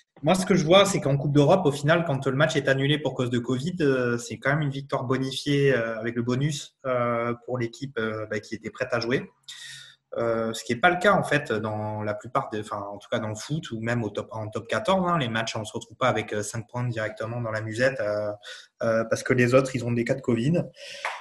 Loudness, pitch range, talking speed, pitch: -25 LUFS, 115-140 Hz, 240 wpm, 125 Hz